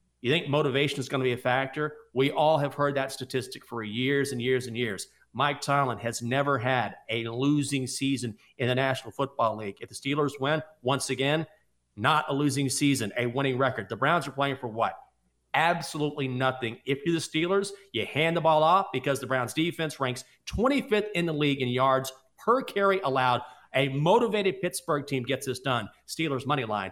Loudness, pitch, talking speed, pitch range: -27 LUFS, 135 Hz, 195 wpm, 125-150 Hz